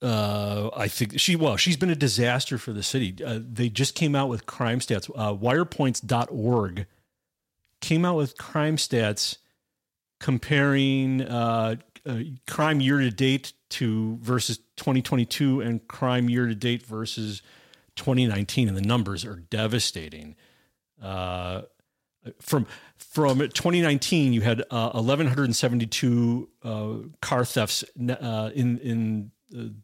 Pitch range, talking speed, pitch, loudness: 110-135 Hz, 130 wpm, 120 Hz, -25 LUFS